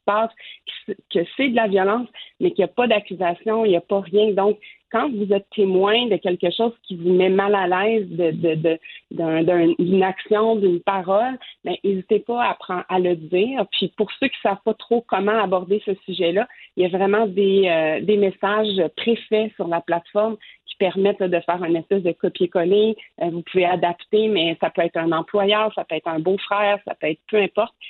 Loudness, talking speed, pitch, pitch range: -20 LUFS, 210 wpm, 195 Hz, 180-215 Hz